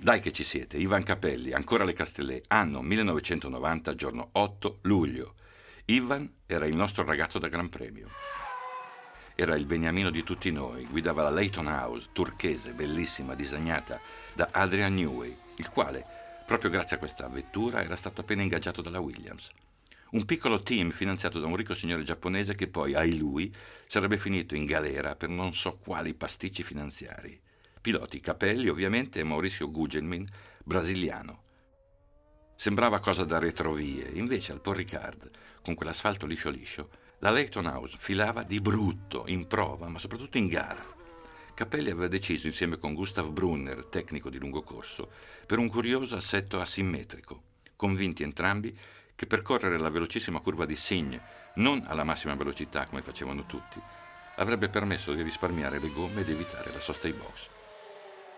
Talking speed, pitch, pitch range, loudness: 150 wpm, 90 Hz, 80-105 Hz, -31 LUFS